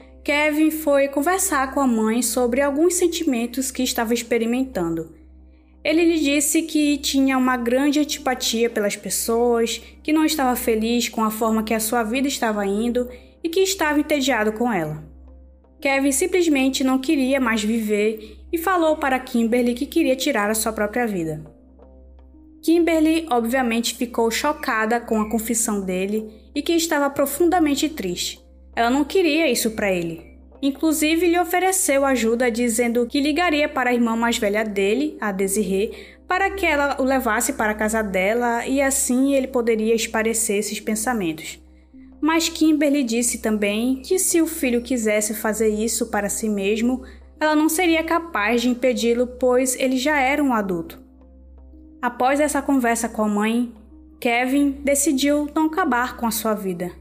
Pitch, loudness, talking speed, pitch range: 245 Hz, -20 LUFS, 155 wpm, 220-290 Hz